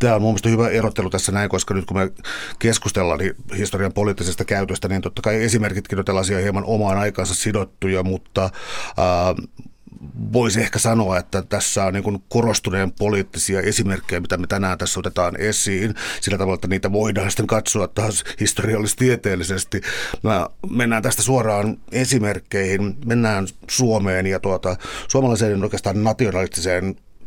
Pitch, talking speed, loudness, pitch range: 100 Hz, 145 wpm, -20 LUFS, 95-110 Hz